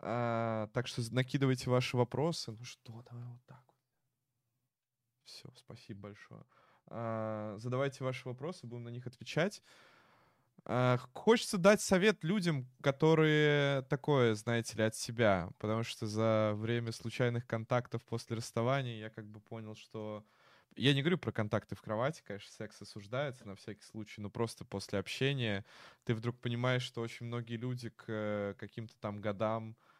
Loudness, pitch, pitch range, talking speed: -35 LUFS, 120 Hz, 110-130 Hz, 150 wpm